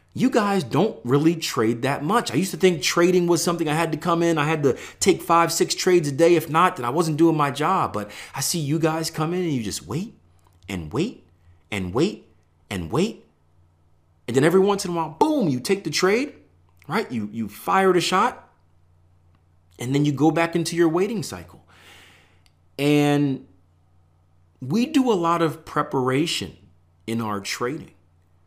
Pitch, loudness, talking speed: 140 Hz, -22 LUFS, 190 wpm